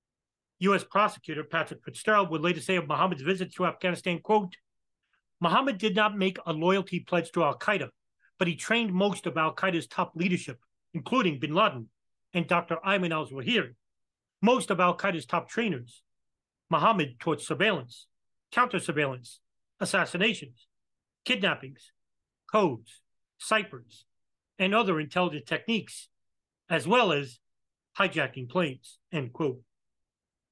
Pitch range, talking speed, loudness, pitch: 140-195 Hz, 120 wpm, -28 LUFS, 170 Hz